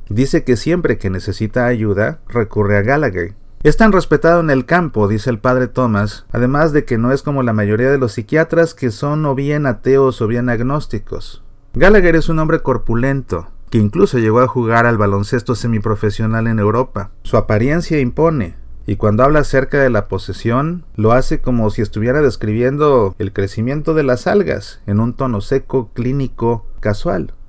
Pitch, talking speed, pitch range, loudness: 125 Hz, 175 wpm, 110-140 Hz, -15 LUFS